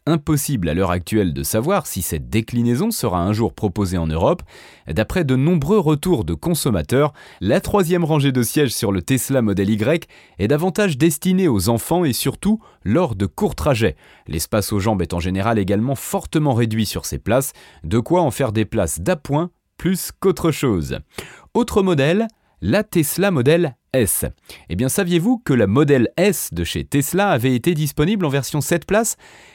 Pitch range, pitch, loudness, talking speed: 110-175 Hz, 140 Hz, -19 LUFS, 175 wpm